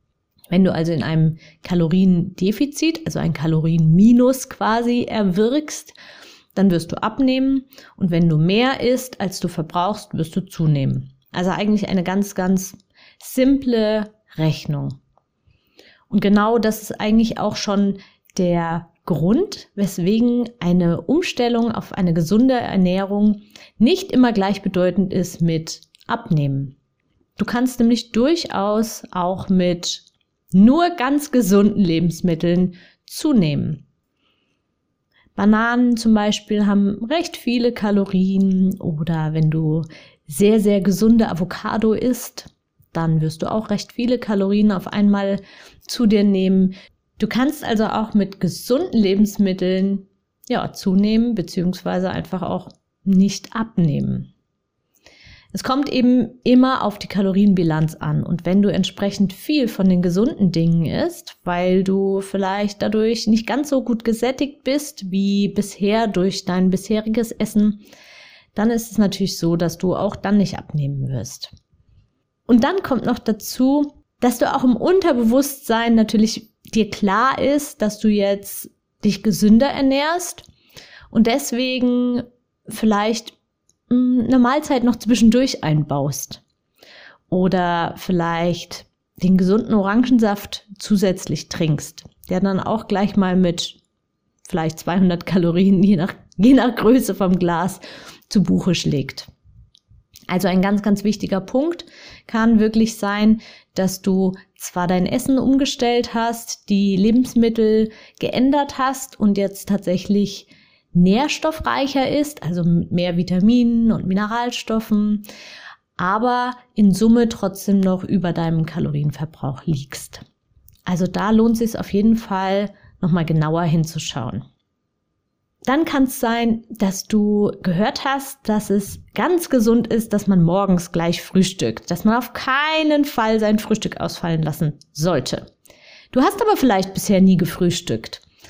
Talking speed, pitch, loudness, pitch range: 125 wpm, 200 Hz, -19 LUFS, 180-235 Hz